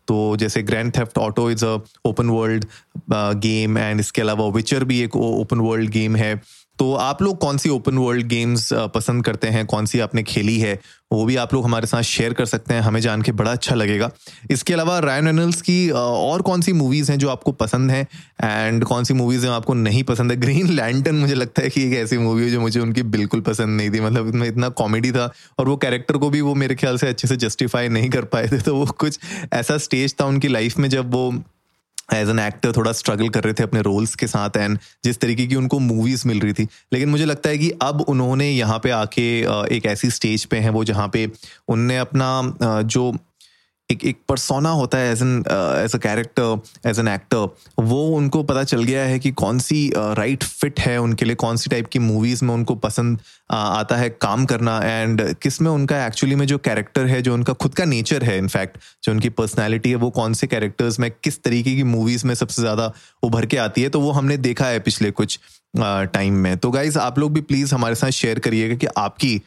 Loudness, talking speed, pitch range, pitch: -19 LUFS, 230 wpm, 110-135 Hz, 120 Hz